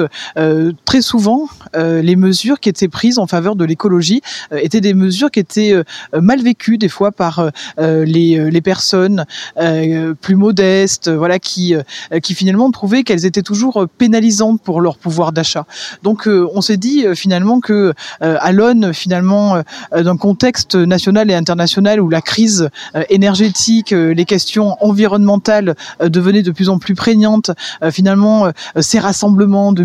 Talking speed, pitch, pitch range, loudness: 175 wpm, 195 Hz, 170-210 Hz, -12 LUFS